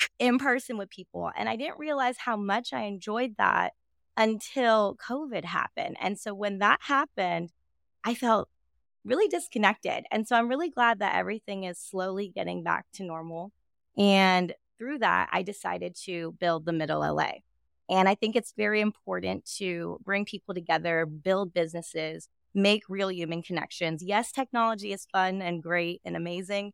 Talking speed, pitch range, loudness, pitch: 160 wpm, 175-225 Hz, -28 LUFS, 200 Hz